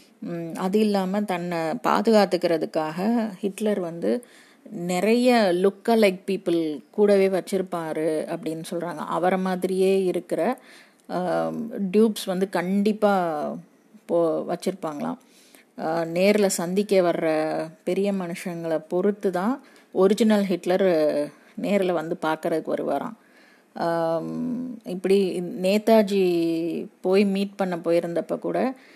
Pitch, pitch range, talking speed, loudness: 190 Hz, 170-215 Hz, 85 wpm, -24 LUFS